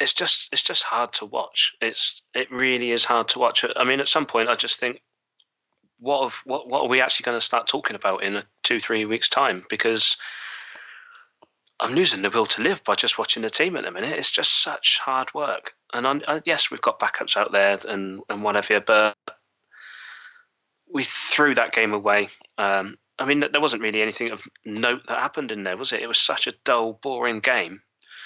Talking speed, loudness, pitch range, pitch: 210 wpm, -22 LUFS, 105-130 Hz, 110 Hz